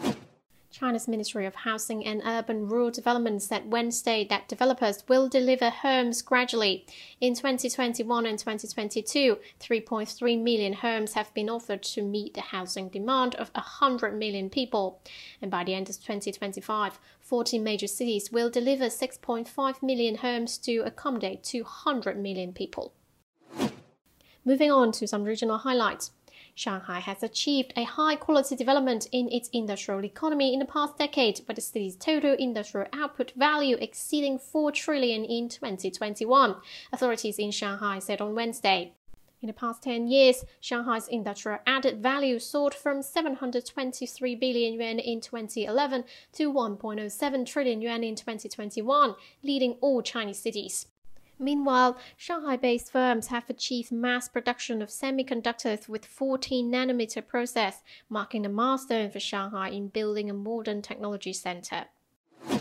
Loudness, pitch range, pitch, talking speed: -28 LUFS, 215-260 Hz, 235 Hz, 140 wpm